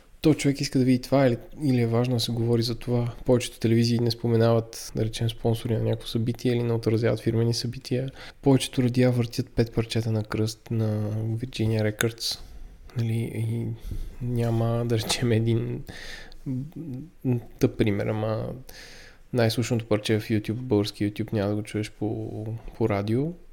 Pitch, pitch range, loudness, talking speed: 115 Hz, 110-125 Hz, -26 LUFS, 160 wpm